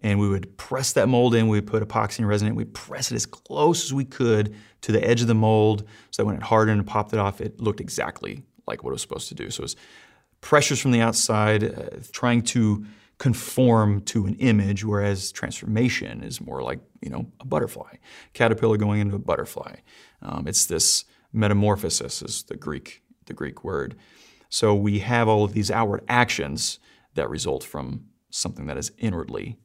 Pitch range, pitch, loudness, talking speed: 105-115 Hz, 110 Hz, -23 LUFS, 200 wpm